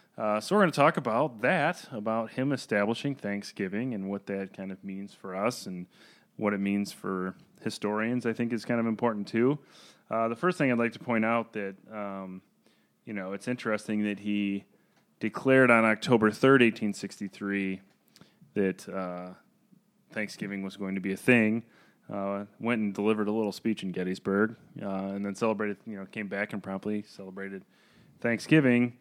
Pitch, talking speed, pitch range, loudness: 105 Hz, 180 wpm, 100-115 Hz, -29 LUFS